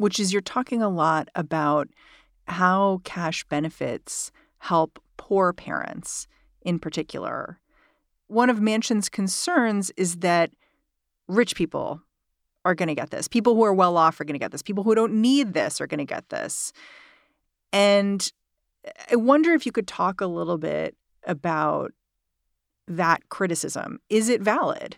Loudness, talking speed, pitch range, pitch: -24 LUFS, 155 wpm, 170-225 Hz, 195 Hz